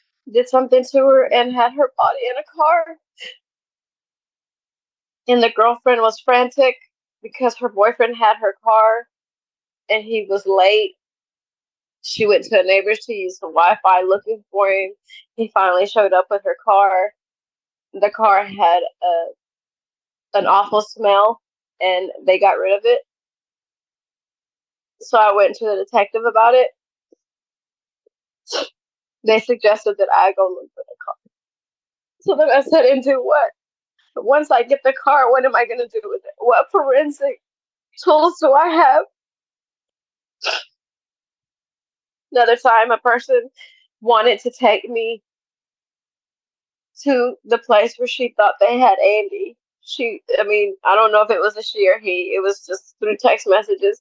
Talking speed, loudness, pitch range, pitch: 150 wpm, -16 LUFS, 210-295 Hz, 235 Hz